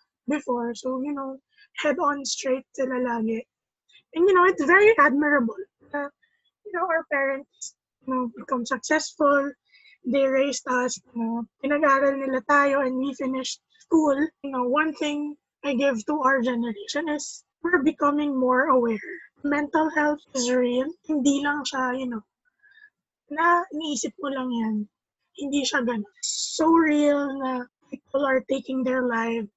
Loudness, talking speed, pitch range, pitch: -24 LUFS, 150 wpm, 255-305 Hz, 280 Hz